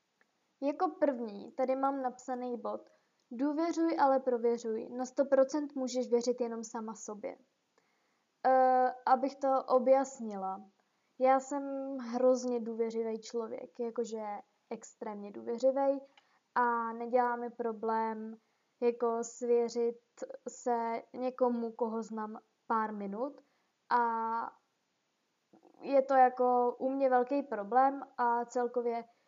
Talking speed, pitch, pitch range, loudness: 100 wpm, 245 Hz, 230-265 Hz, -33 LUFS